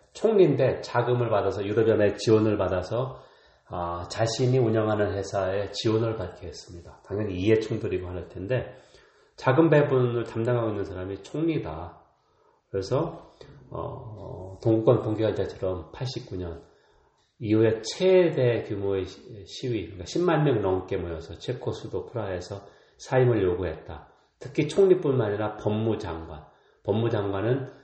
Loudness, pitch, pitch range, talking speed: -26 LUFS, 110 Hz, 95-130 Hz, 295 characters per minute